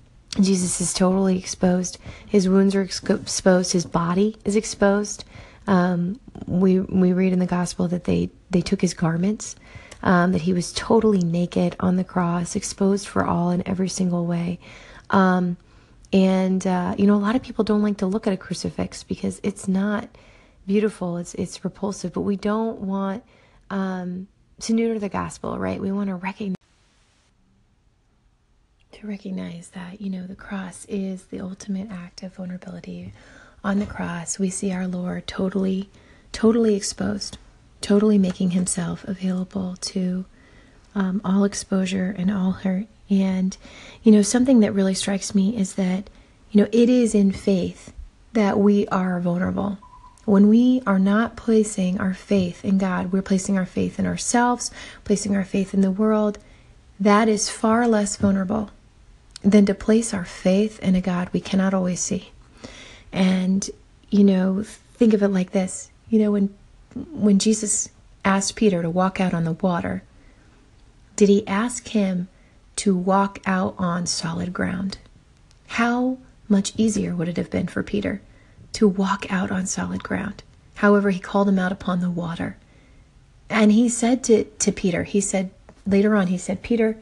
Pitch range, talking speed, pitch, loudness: 185-205 Hz, 165 wpm, 195 Hz, -22 LUFS